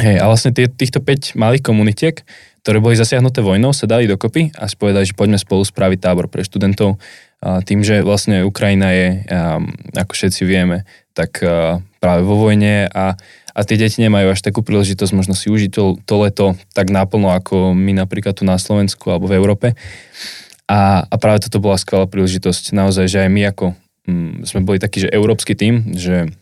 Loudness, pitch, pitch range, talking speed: -14 LUFS, 100 Hz, 95-105 Hz, 180 wpm